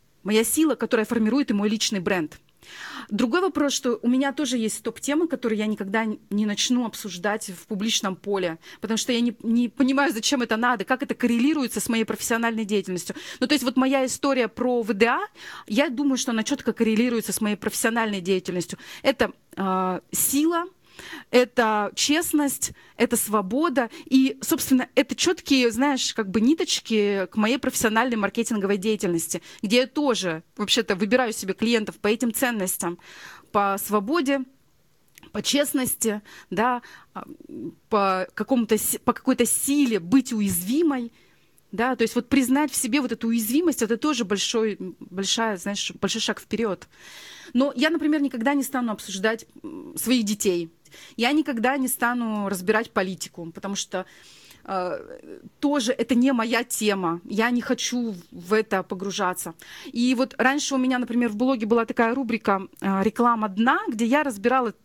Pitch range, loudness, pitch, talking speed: 210-265 Hz, -23 LUFS, 230 Hz, 150 wpm